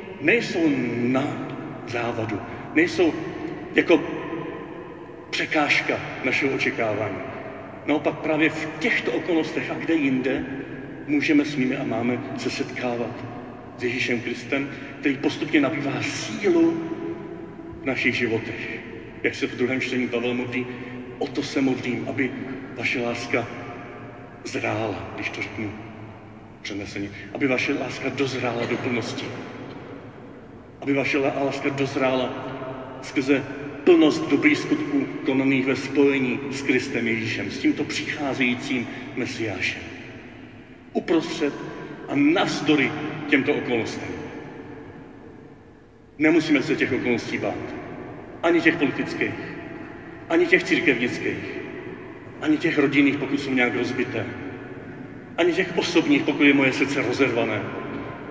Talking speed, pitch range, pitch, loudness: 110 wpm, 120-160 Hz, 135 Hz, -24 LUFS